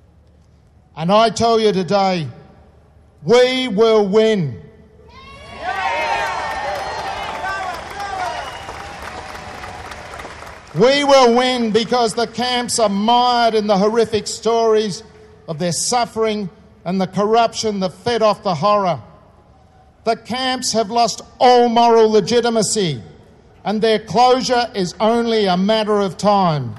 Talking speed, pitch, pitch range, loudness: 105 wpm, 220 Hz, 185-235 Hz, -16 LUFS